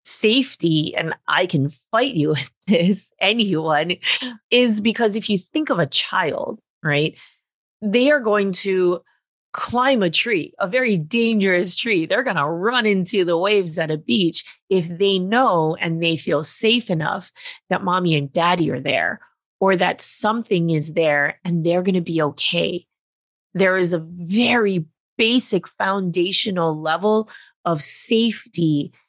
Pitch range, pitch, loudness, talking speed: 165-220 Hz, 185 Hz, -19 LUFS, 150 wpm